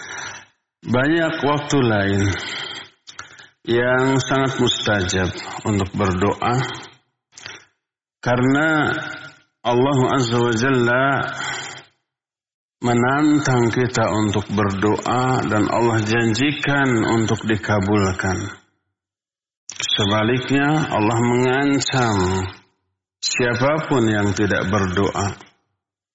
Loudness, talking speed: -19 LUFS, 65 wpm